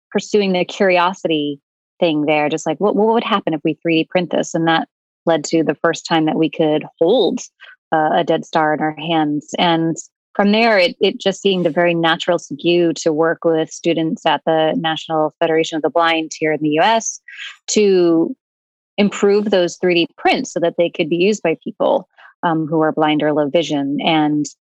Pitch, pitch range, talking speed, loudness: 165 Hz, 160-185 Hz, 195 wpm, -17 LUFS